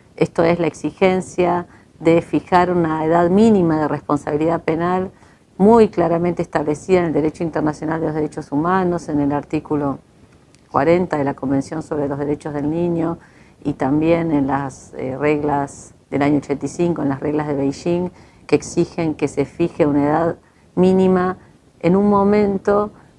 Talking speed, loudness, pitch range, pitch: 155 wpm, -18 LUFS, 145-175 Hz, 160 Hz